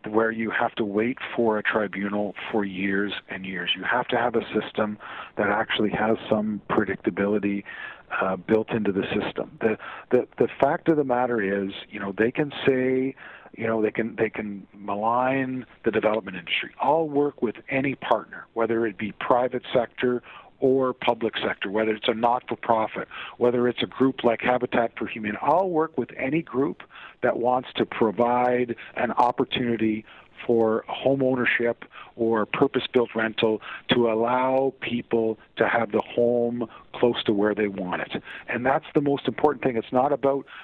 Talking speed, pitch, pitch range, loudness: 175 wpm, 115 Hz, 105-125 Hz, -25 LUFS